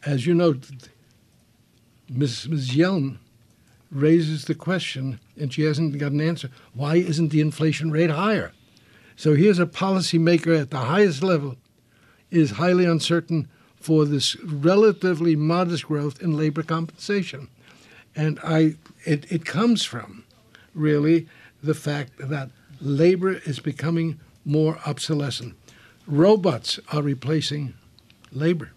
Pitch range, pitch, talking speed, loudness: 140-170 Hz, 155 Hz, 120 wpm, -22 LUFS